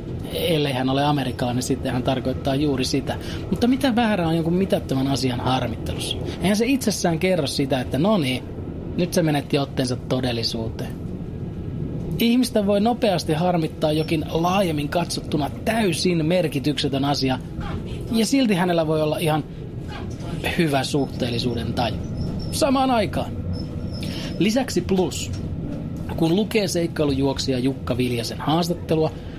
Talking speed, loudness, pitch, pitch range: 125 wpm, -23 LUFS, 150 Hz, 125-180 Hz